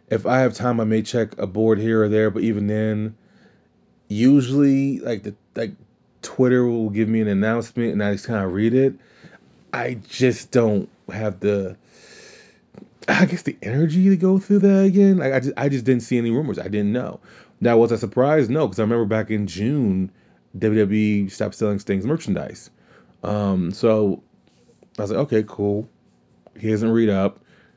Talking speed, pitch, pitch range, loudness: 185 wpm, 110 Hz, 105-125 Hz, -20 LUFS